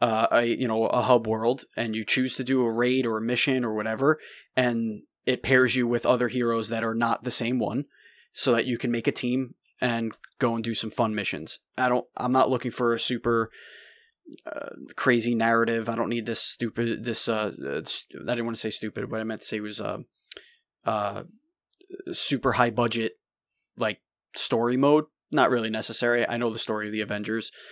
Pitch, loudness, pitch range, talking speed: 120 Hz, -26 LUFS, 115-130 Hz, 210 wpm